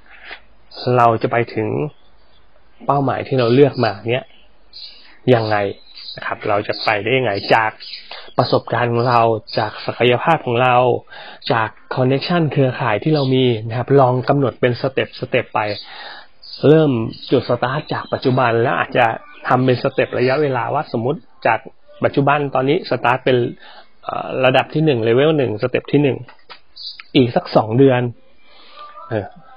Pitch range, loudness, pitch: 115-140 Hz, -17 LUFS, 125 Hz